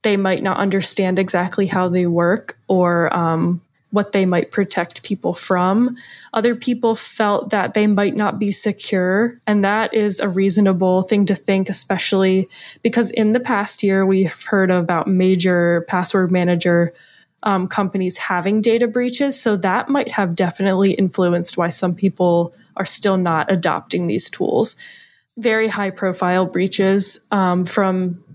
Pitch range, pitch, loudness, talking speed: 180-210 Hz, 195 Hz, -18 LUFS, 150 wpm